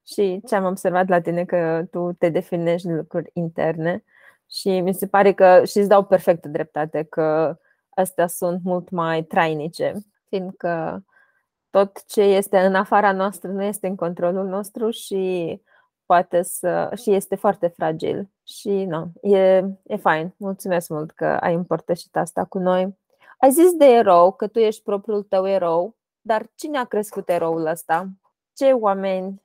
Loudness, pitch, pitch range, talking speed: -20 LUFS, 185 Hz, 175-200 Hz, 165 wpm